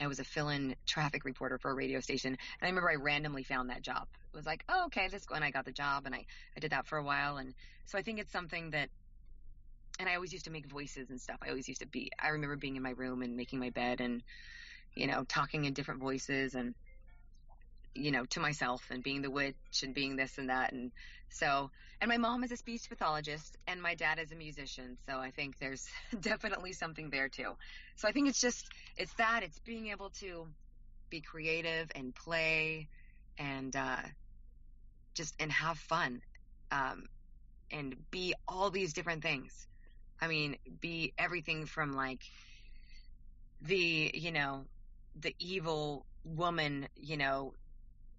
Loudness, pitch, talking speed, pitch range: -37 LUFS, 145 Hz, 195 wpm, 130-165 Hz